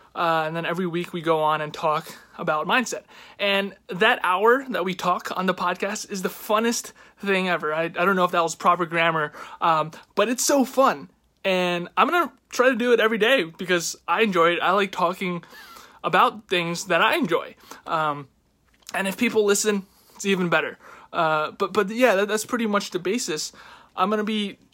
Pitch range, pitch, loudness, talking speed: 170-215 Hz, 185 Hz, -23 LUFS, 200 wpm